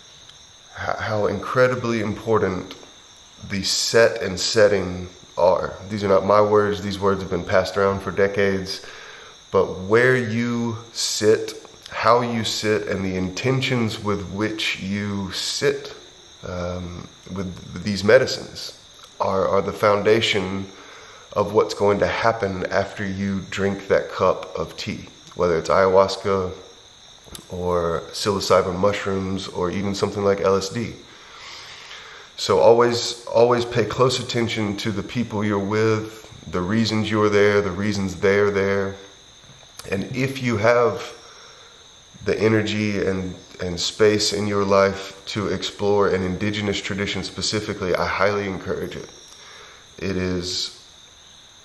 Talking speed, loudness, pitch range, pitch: 125 wpm, -21 LUFS, 95-110 Hz, 100 Hz